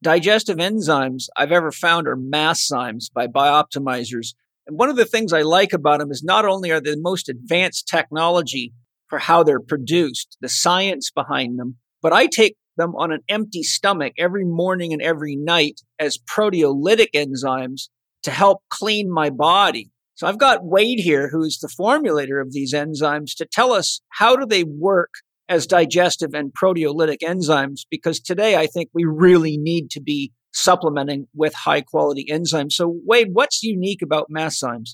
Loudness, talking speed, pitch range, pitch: -18 LUFS, 175 wpm, 145-180 Hz, 160 Hz